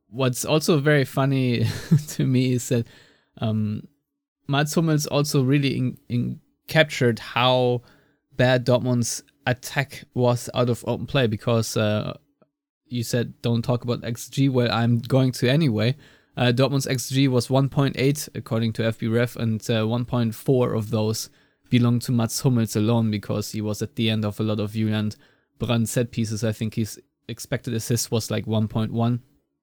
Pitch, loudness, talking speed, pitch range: 120 Hz, -23 LUFS, 160 wpm, 115-135 Hz